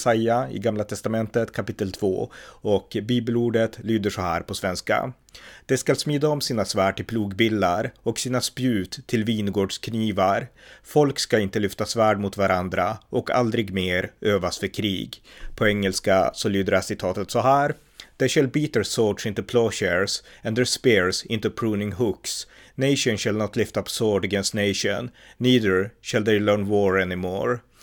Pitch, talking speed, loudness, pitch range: 110 Hz, 160 wpm, -23 LUFS, 100-120 Hz